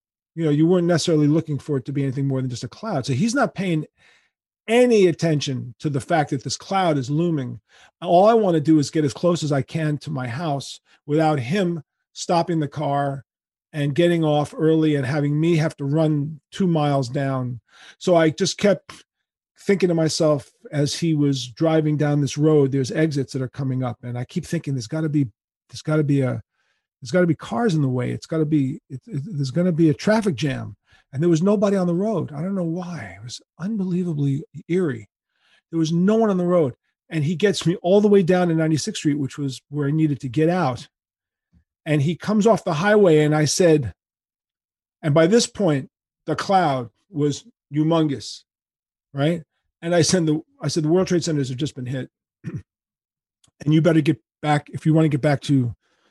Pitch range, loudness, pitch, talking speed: 140-170 Hz, -21 LUFS, 155 Hz, 215 wpm